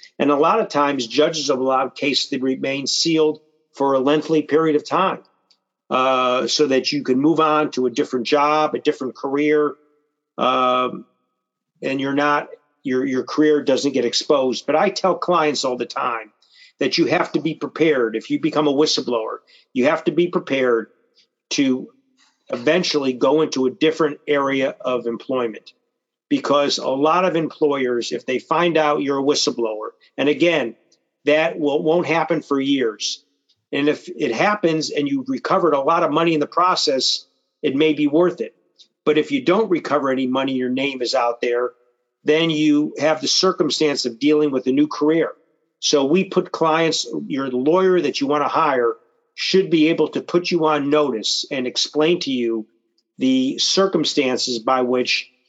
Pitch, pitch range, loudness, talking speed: 150 Hz, 130-160 Hz, -19 LUFS, 175 wpm